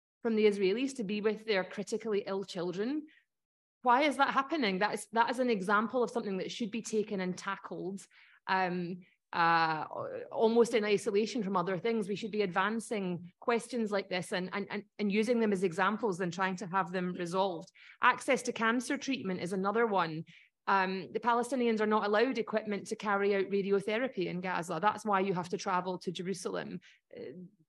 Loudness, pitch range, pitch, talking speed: -32 LUFS, 190-230 Hz, 205 Hz, 185 wpm